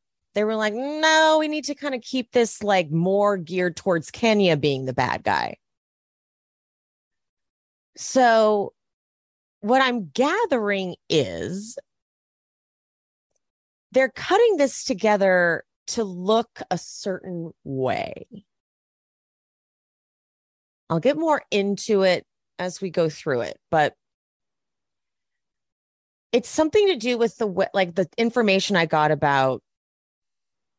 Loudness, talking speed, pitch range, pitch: -22 LUFS, 110 wpm, 175-250 Hz, 200 Hz